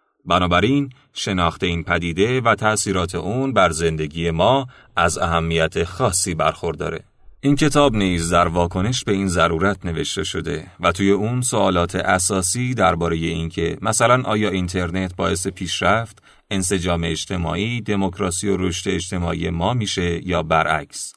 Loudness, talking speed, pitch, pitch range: -20 LUFS, 130 wpm, 95 Hz, 85-105 Hz